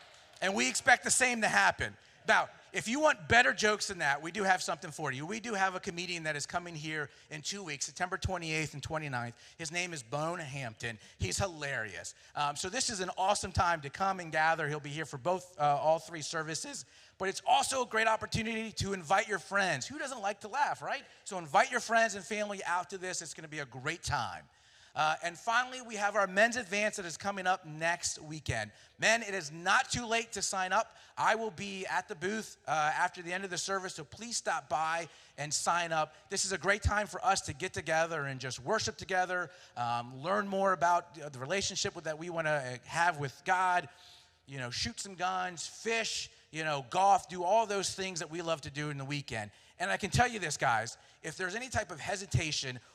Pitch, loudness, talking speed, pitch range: 180 Hz, -33 LUFS, 225 wpm, 155-200 Hz